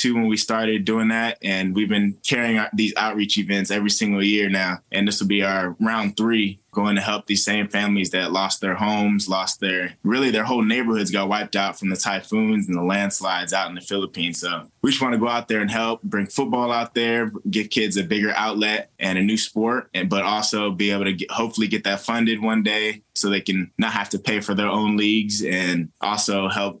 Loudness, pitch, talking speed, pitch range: -21 LUFS, 105 Hz, 230 wpm, 100-110 Hz